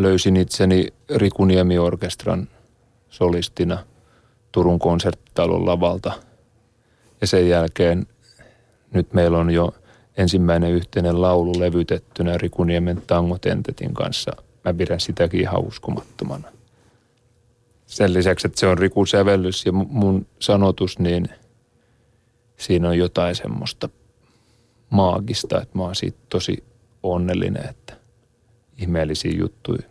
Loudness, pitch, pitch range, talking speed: -20 LUFS, 95 Hz, 90-115 Hz, 100 wpm